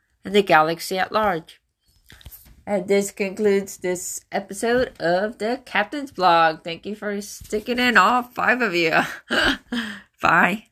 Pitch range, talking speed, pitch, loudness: 185-230 Hz, 135 wpm, 205 Hz, -21 LUFS